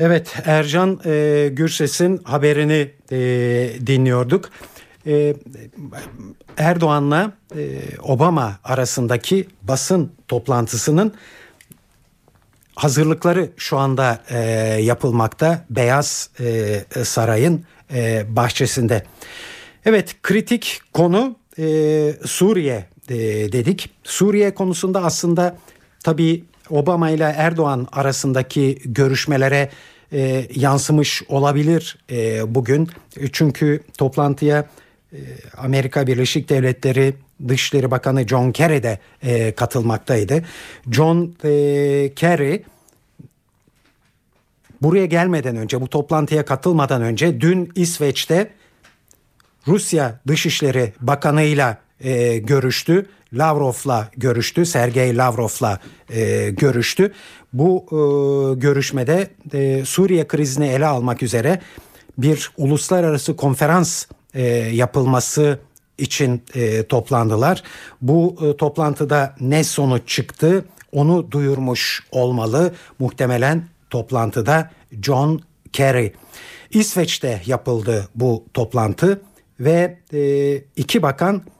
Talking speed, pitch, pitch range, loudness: 90 wpm, 140 Hz, 125-160 Hz, -18 LUFS